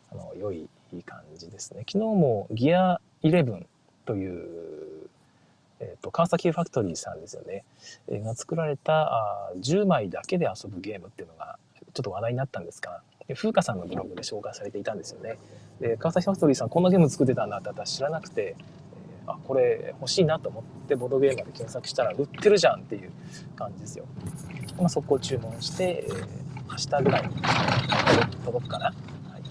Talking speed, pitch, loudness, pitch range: 385 characters per minute, 165 Hz, -27 LUFS, 130-195 Hz